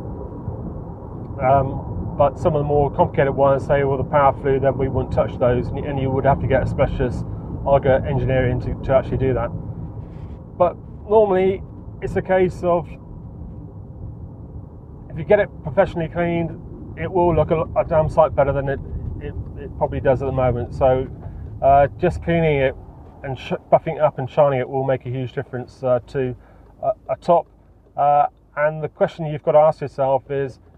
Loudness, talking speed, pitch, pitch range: -20 LUFS, 185 wpm, 135 Hz, 125-155 Hz